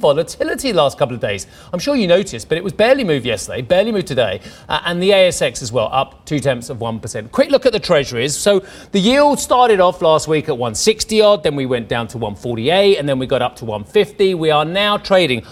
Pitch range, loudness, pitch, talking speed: 140-205 Hz, -16 LUFS, 180 Hz, 235 wpm